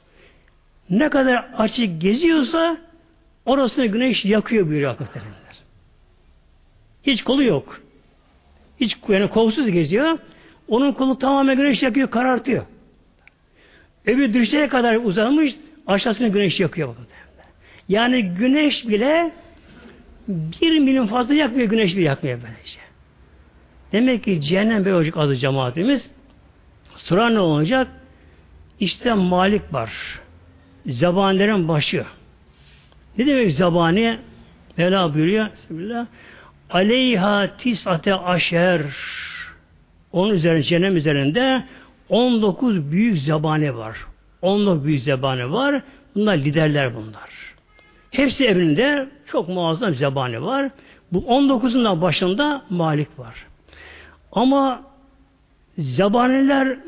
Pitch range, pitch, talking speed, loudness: 155-255 Hz, 200 Hz, 95 wpm, -19 LUFS